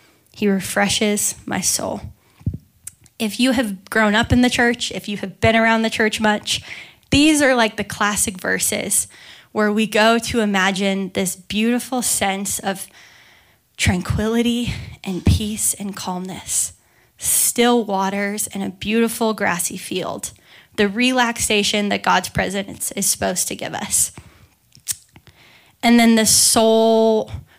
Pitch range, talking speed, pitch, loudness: 195-230 Hz, 135 wpm, 215 Hz, -18 LUFS